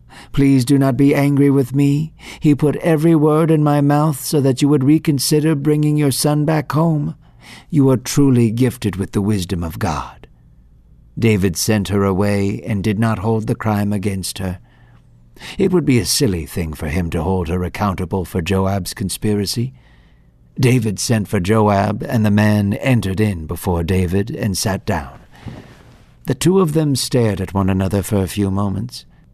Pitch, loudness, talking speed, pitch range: 110 Hz, -17 LUFS, 175 wpm, 100-140 Hz